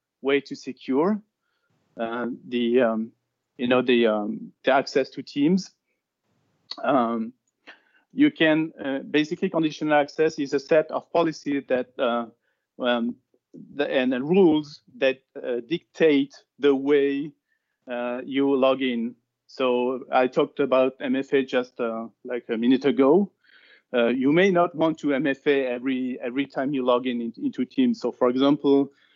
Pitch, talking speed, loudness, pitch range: 135 Hz, 145 wpm, -24 LUFS, 125-155 Hz